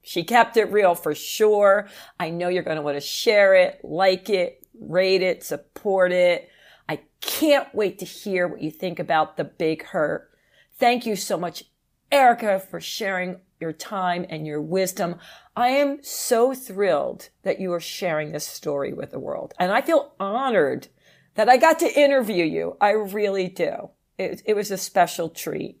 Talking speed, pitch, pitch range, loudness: 180 wpm, 190 Hz, 175-220 Hz, -22 LUFS